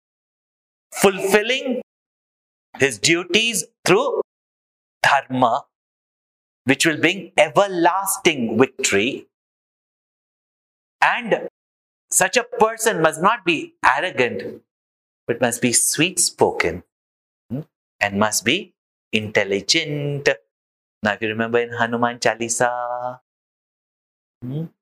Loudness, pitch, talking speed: -19 LUFS, 135 Hz, 80 wpm